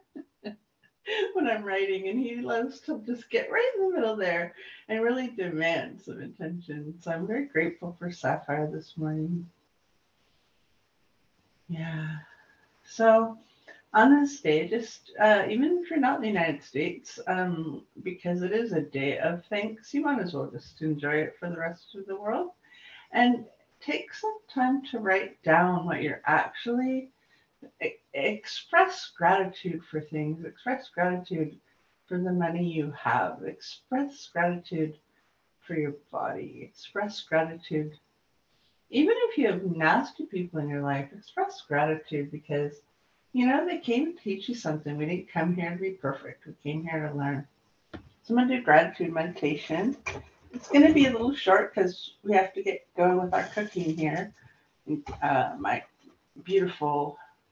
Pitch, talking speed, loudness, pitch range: 185 Hz, 155 wpm, -28 LUFS, 160-245 Hz